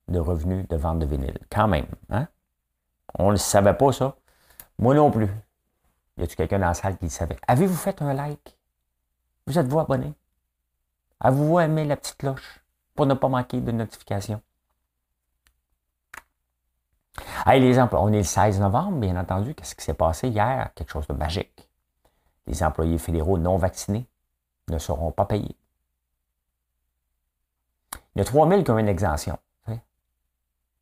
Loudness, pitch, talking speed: -23 LUFS, 85 Hz, 160 wpm